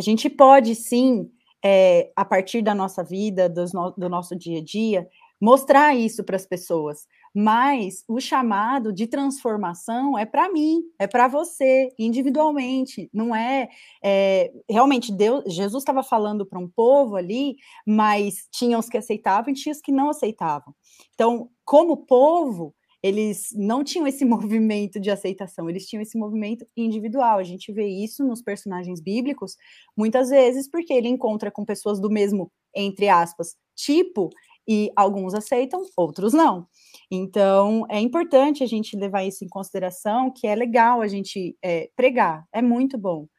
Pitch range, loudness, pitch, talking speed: 195-260 Hz, -21 LUFS, 220 Hz, 160 wpm